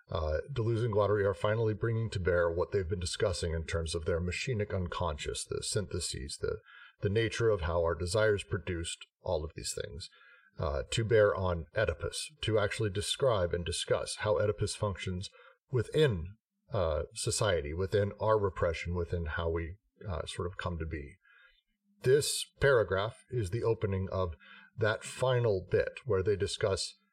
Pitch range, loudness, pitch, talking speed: 85-115 Hz, -32 LUFS, 100 Hz, 160 wpm